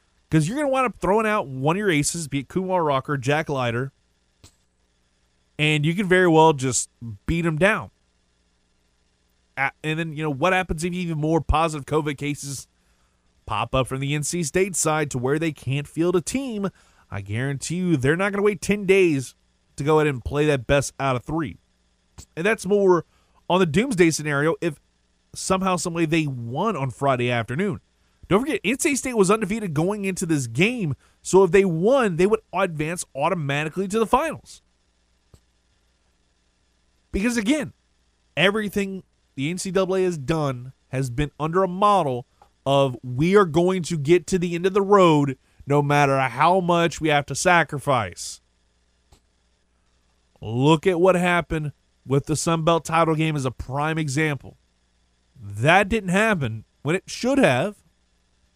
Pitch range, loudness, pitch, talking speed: 115-185 Hz, -22 LUFS, 150 Hz, 165 wpm